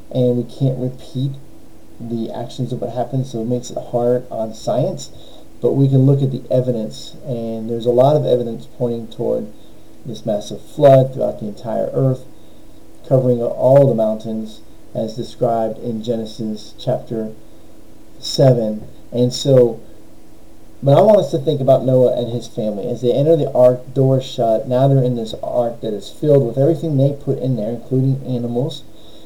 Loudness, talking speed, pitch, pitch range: -17 LUFS, 170 wpm, 125 Hz, 115-130 Hz